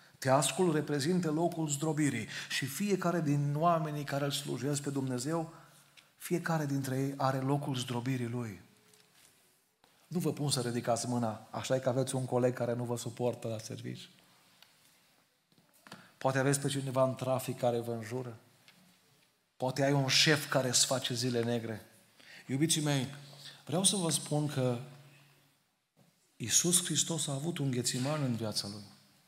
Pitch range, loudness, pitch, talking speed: 125-150 Hz, -32 LUFS, 135 Hz, 145 wpm